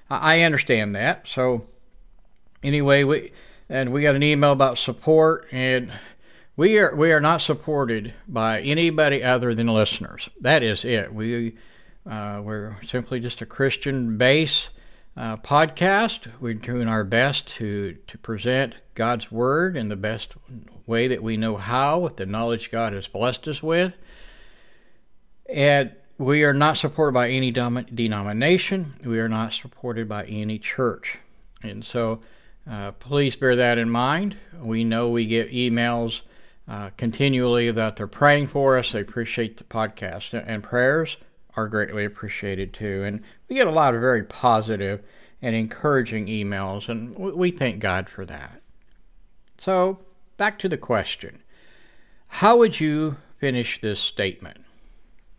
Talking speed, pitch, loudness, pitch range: 145 wpm, 120 Hz, -22 LUFS, 110-145 Hz